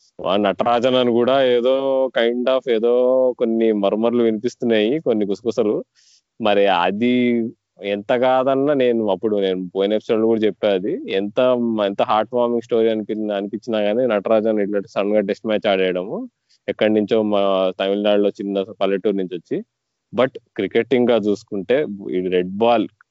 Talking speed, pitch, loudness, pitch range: 135 wpm, 110 Hz, -19 LUFS, 100-120 Hz